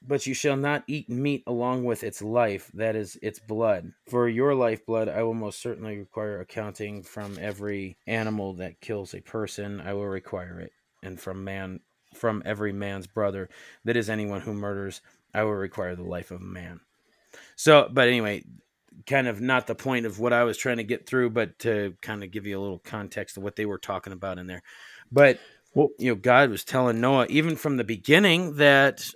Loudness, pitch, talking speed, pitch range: -26 LUFS, 110 Hz, 210 wpm, 100-125 Hz